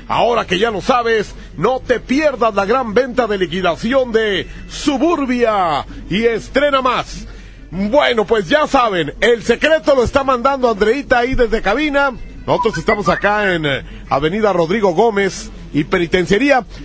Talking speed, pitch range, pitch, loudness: 140 wpm, 200-265 Hz, 230 Hz, -15 LUFS